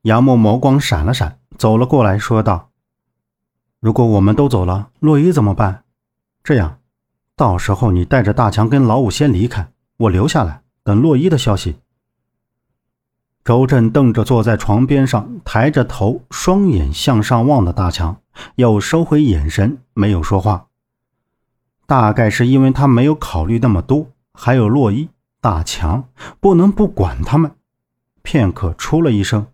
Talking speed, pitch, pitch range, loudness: 225 characters per minute, 115 Hz, 105-135 Hz, -14 LUFS